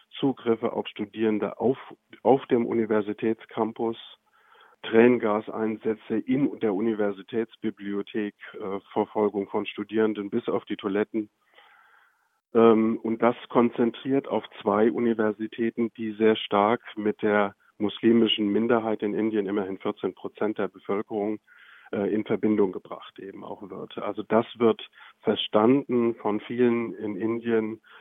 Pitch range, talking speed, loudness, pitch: 105-115 Hz, 120 wpm, -26 LUFS, 110 Hz